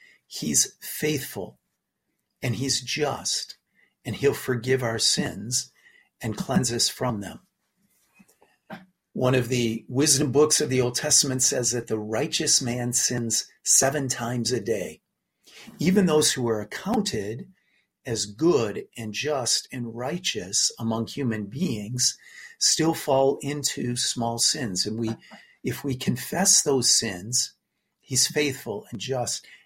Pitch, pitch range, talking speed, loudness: 130 Hz, 115-150 Hz, 130 wpm, -24 LUFS